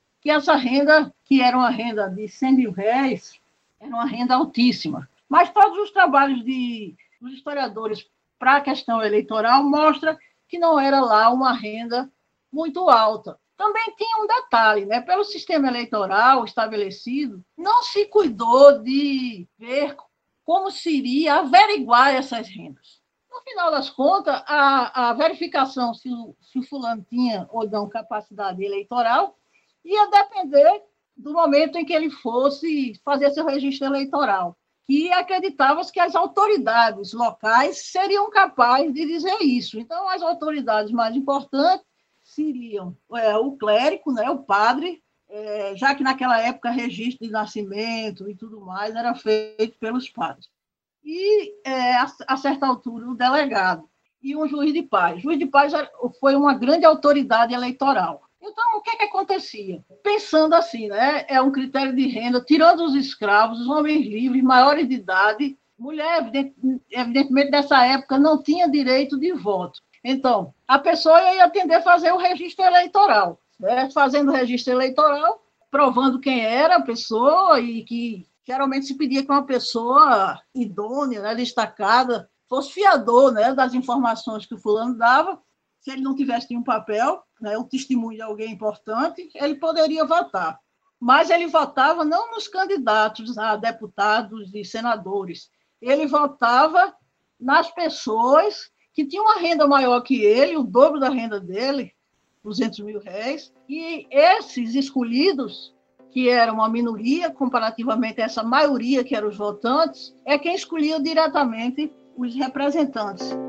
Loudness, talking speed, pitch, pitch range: -20 LUFS, 150 wpm, 265 Hz, 230-315 Hz